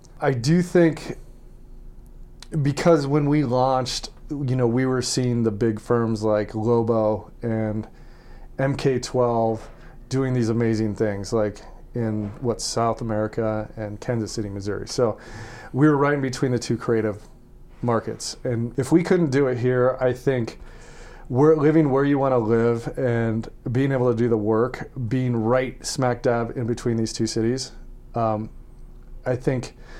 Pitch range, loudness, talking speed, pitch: 115-135 Hz, -23 LUFS, 155 wpm, 120 Hz